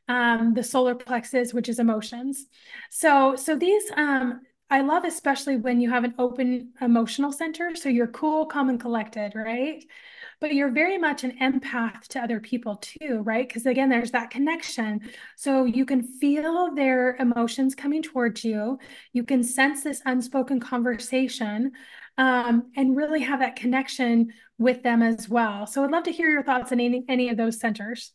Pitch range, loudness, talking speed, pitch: 240-280 Hz, -24 LUFS, 175 wpm, 255 Hz